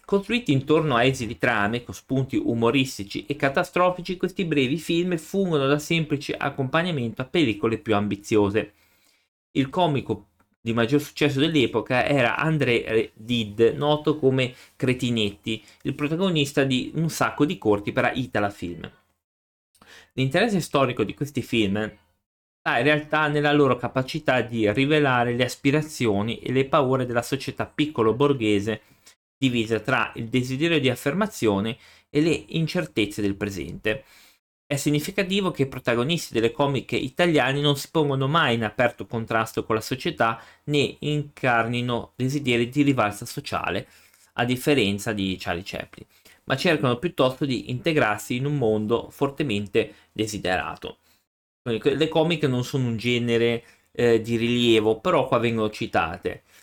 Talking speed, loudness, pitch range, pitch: 135 wpm, -24 LUFS, 115-150 Hz, 130 Hz